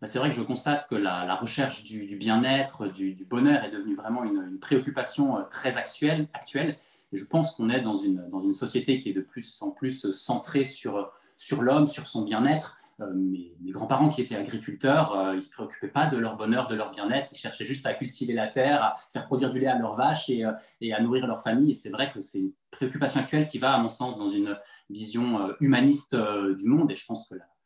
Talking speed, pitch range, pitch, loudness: 245 wpm, 110-150 Hz, 130 Hz, -27 LUFS